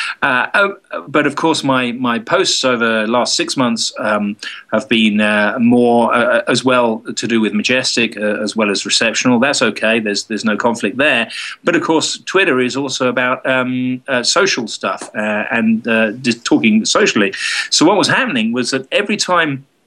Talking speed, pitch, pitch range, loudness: 185 wpm, 125 Hz, 110-145 Hz, -14 LUFS